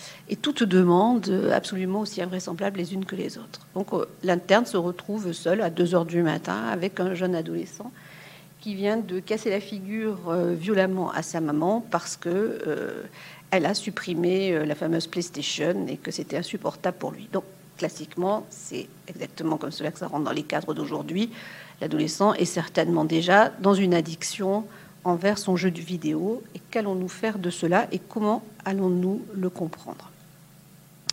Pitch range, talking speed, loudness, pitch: 170-200 Hz, 160 wpm, -26 LUFS, 185 Hz